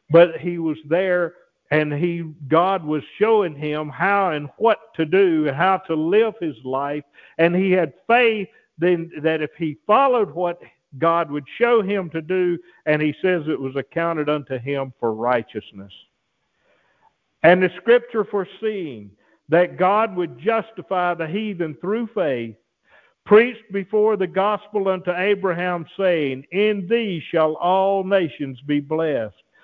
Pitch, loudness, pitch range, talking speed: 175 Hz, -20 LUFS, 150-195 Hz, 150 wpm